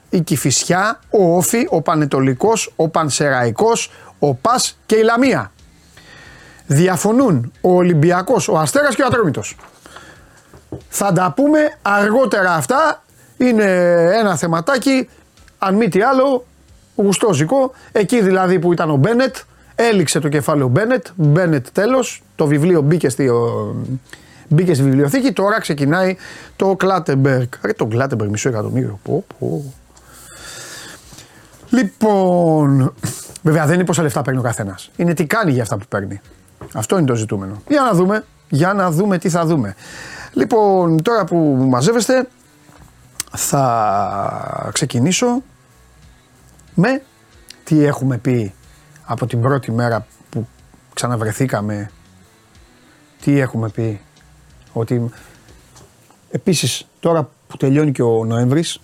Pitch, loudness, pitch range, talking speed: 160 Hz, -16 LUFS, 130-200 Hz, 125 wpm